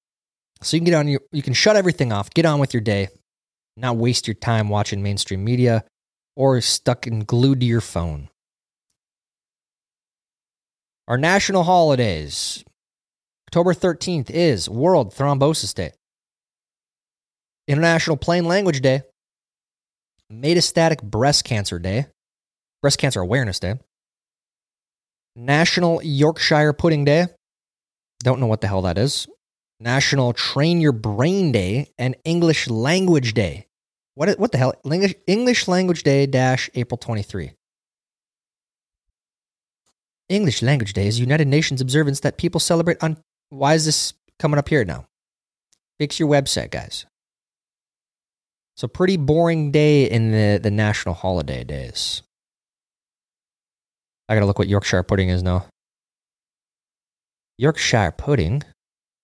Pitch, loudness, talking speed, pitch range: 135 Hz, -19 LUFS, 125 wpm, 110-160 Hz